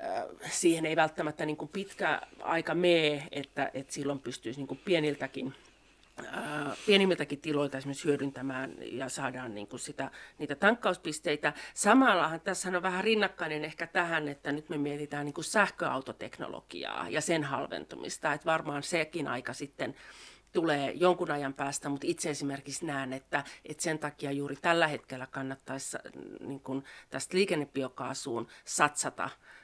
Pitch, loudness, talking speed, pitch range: 150 Hz, -32 LUFS, 140 wpm, 140-170 Hz